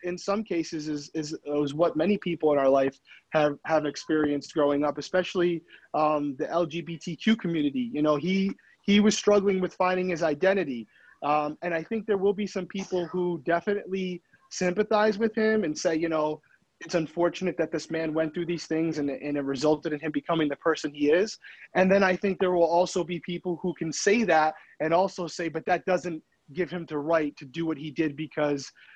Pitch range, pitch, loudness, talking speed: 155-185 Hz, 170 Hz, -27 LUFS, 205 wpm